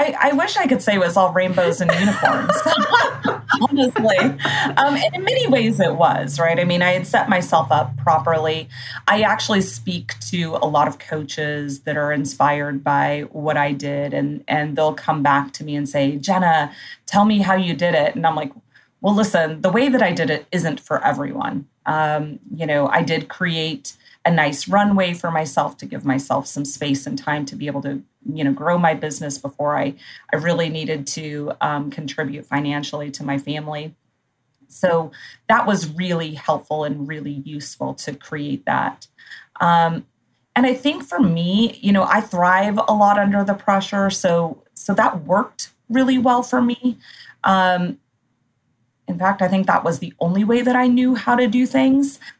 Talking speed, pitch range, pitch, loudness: 190 wpm, 145-200 Hz, 165 Hz, -19 LUFS